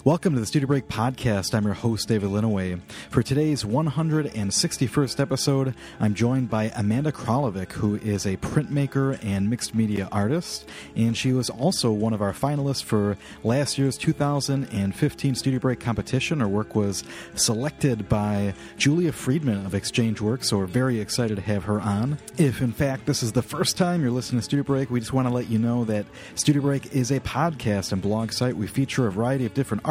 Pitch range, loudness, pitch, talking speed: 105-135 Hz, -24 LUFS, 120 Hz, 195 wpm